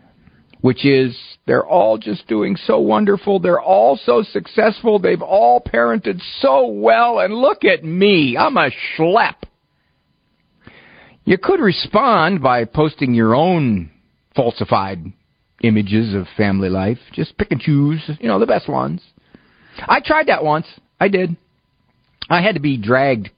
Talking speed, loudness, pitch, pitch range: 145 wpm, -16 LUFS, 135 Hz, 110-185 Hz